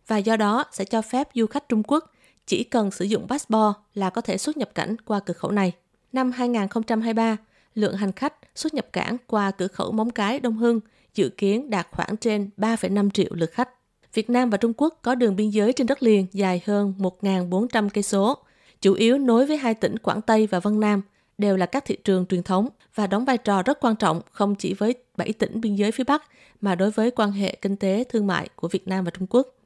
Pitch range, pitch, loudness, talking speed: 195-240 Hz, 215 Hz, -23 LUFS, 235 wpm